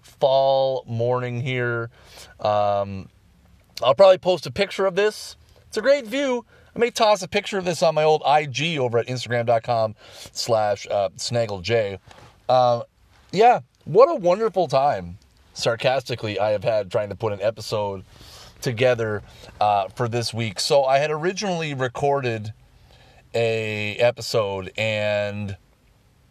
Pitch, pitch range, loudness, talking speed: 120 Hz, 105-155 Hz, -22 LUFS, 135 wpm